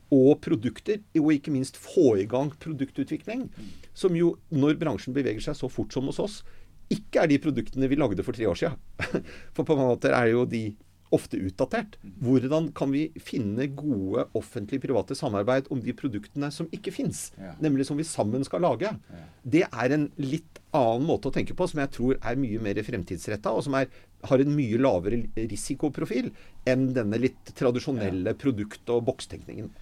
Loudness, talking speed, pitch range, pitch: -27 LUFS, 180 wpm, 115-145 Hz, 135 Hz